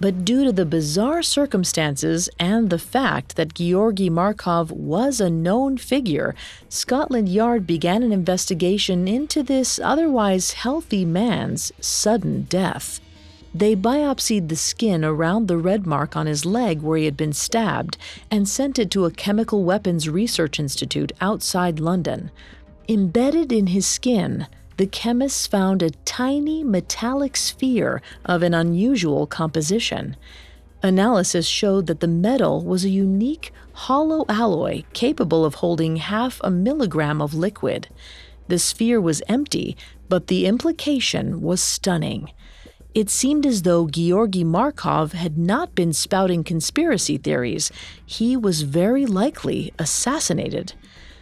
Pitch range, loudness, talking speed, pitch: 170-235 Hz, -20 LUFS, 135 wpm, 190 Hz